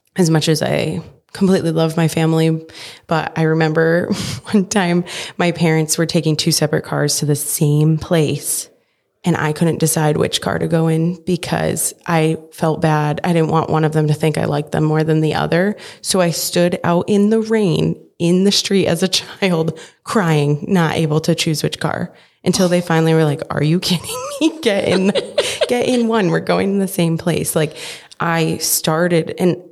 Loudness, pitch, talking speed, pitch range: -16 LUFS, 165 Hz, 195 wpm, 160-185 Hz